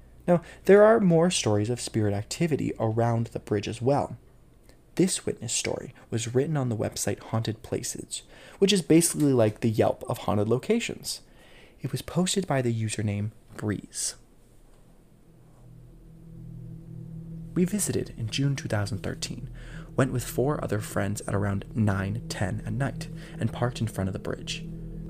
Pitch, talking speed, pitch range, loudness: 125 Hz, 145 wpm, 110-160 Hz, -27 LUFS